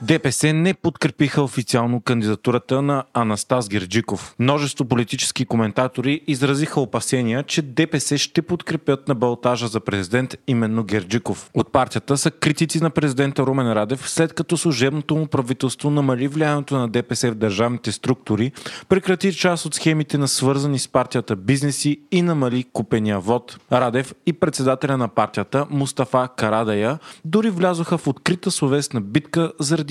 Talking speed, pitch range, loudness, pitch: 140 wpm, 120-155 Hz, -20 LUFS, 135 Hz